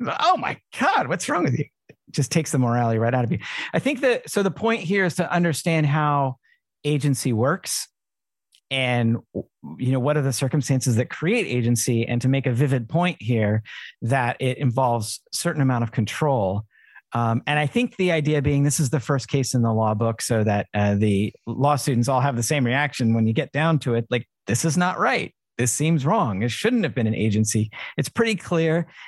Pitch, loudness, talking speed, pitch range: 130 Hz, -22 LUFS, 210 wpm, 115-155 Hz